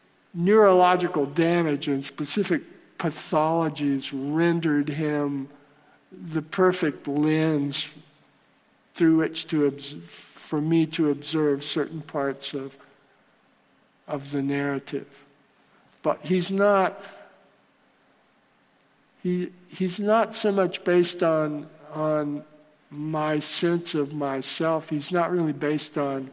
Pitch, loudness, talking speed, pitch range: 155 Hz, -25 LUFS, 100 wpm, 145-175 Hz